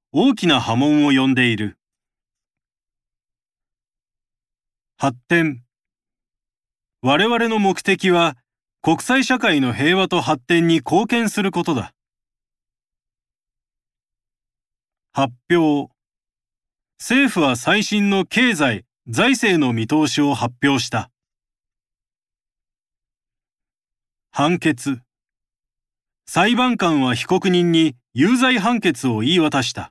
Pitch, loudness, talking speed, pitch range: 145 Hz, -18 LUFS, 155 characters per minute, 120-185 Hz